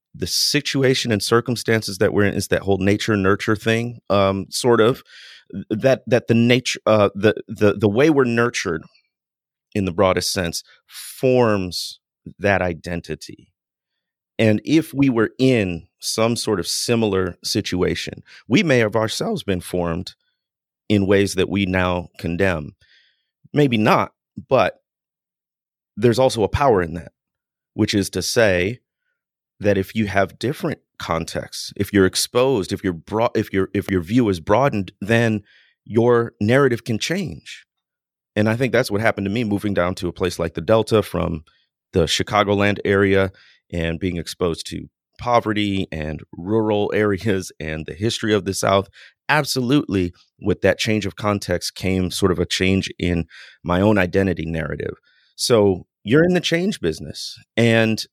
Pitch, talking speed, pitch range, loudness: 100 Hz, 155 wpm, 95-115 Hz, -20 LUFS